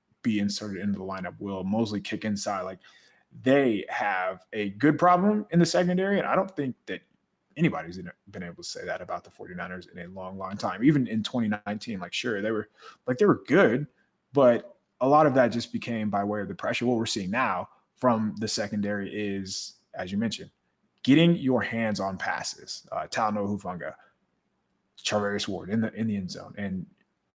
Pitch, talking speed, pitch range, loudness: 105 Hz, 195 wpm, 100-120 Hz, -27 LUFS